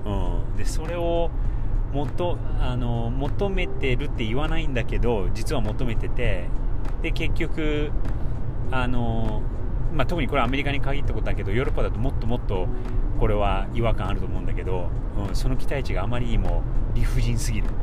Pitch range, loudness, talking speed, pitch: 105-125 Hz, -27 LUFS, 345 characters per minute, 115 Hz